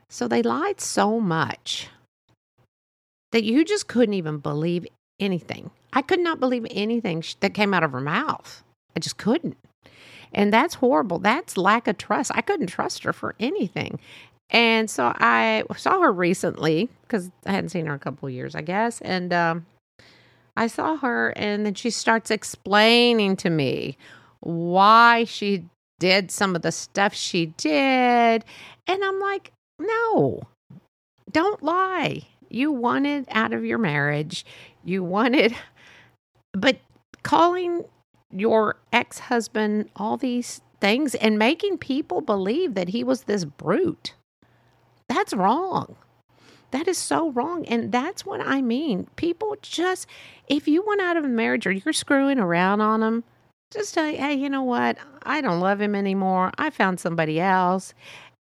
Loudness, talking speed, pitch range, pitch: -23 LUFS, 155 wpm, 185-285 Hz, 225 Hz